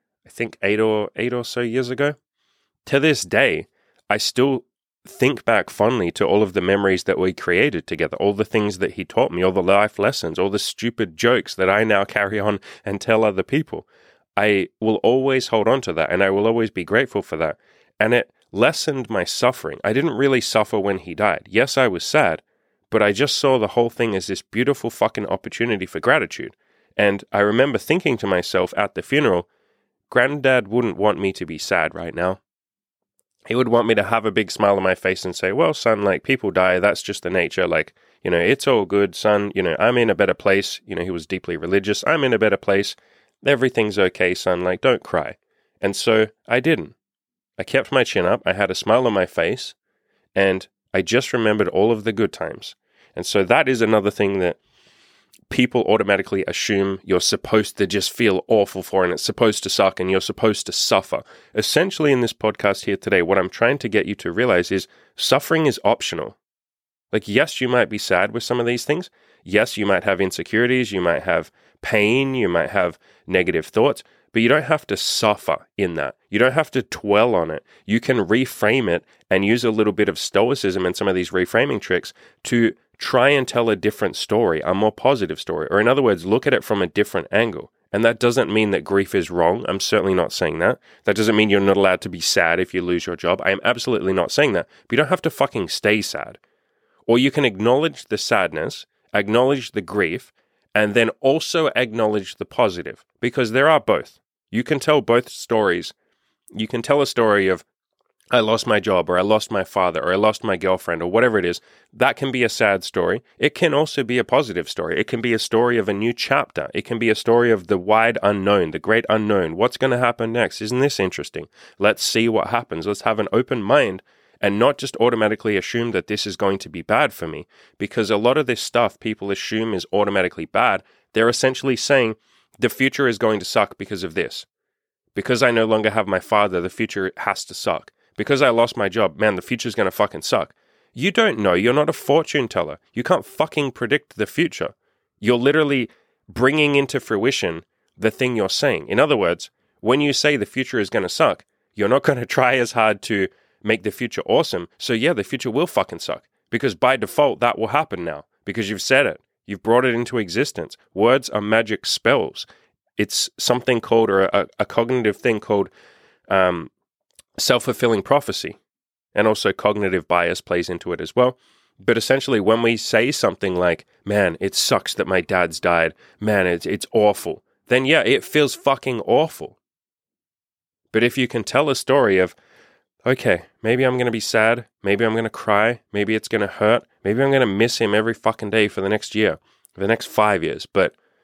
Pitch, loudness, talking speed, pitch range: 110 Hz, -20 LUFS, 215 wpm, 100-120 Hz